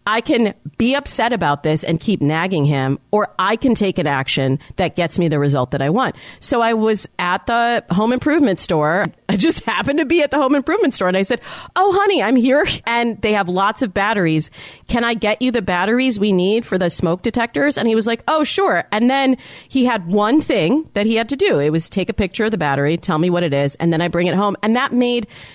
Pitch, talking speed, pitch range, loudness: 215 Hz, 250 wpm, 175-250 Hz, -17 LUFS